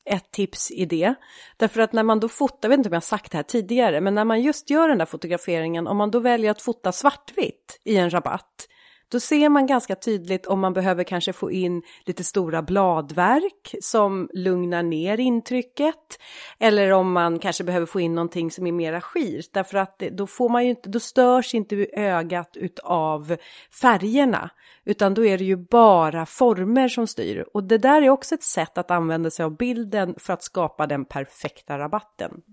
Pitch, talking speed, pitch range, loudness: 195 Hz, 200 wpm, 175-240 Hz, -22 LUFS